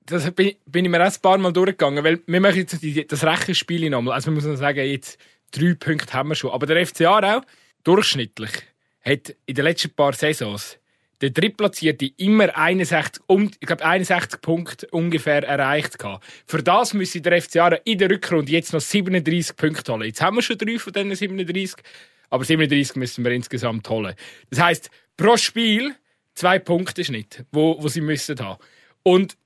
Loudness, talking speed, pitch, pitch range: -20 LUFS, 175 wpm, 165 Hz, 145-185 Hz